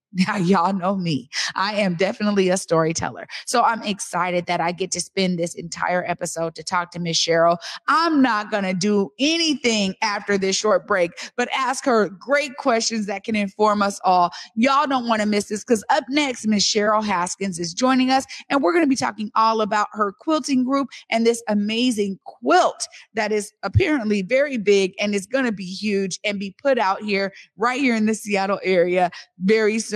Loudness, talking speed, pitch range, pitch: -21 LUFS, 200 wpm, 190-230 Hz, 205 Hz